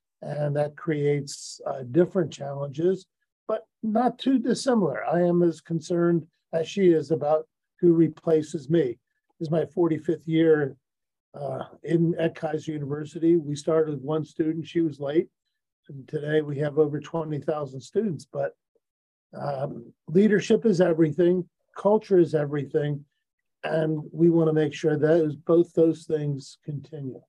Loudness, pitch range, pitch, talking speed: -25 LUFS, 150-175 Hz, 160 Hz, 140 wpm